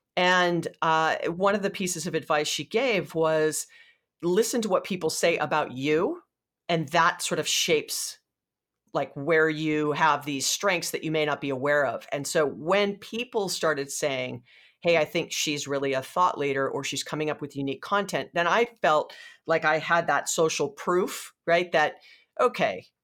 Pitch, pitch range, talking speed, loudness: 160 Hz, 150-185 Hz, 180 wpm, -26 LUFS